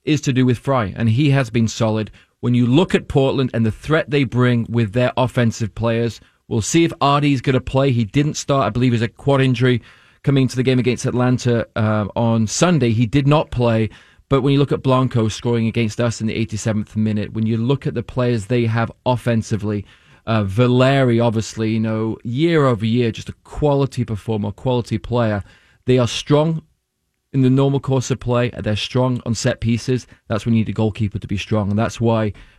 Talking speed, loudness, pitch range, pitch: 215 wpm, -18 LUFS, 110-130 Hz, 120 Hz